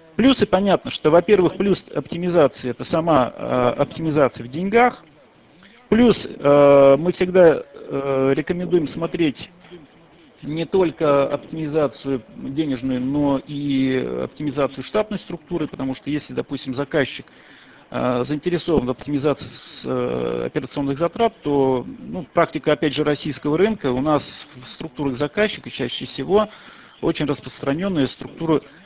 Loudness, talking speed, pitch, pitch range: -20 LUFS, 110 wpm, 150 Hz, 135-175 Hz